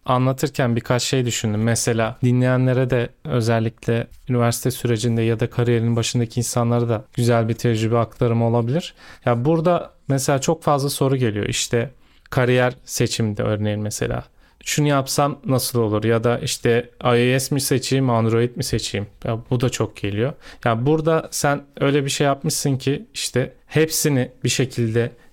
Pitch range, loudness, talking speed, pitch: 115-135 Hz, -20 LUFS, 150 wpm, 120 Hz